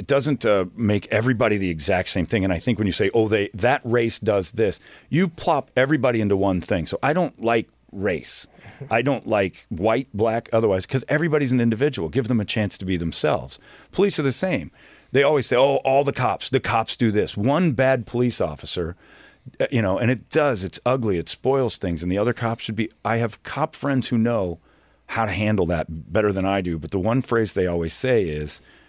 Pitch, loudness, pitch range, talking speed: 115 Hz, -22 LUFS, 95-130 Hz, 220 wpm